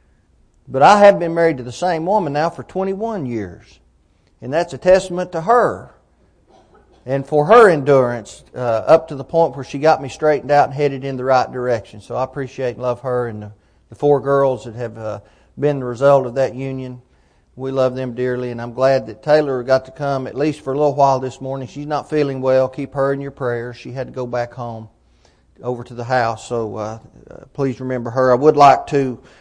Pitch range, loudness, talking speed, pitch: 120-145 Hz, -17 LUFS, 220 wpm, 130 Hz